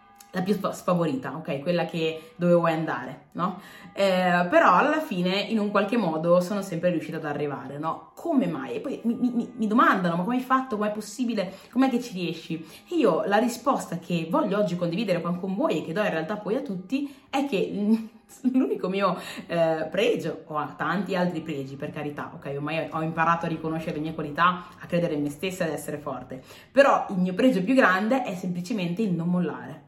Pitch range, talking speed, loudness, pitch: 160-215 Hz, 205 wpm, -26 LUFS, 180 Hz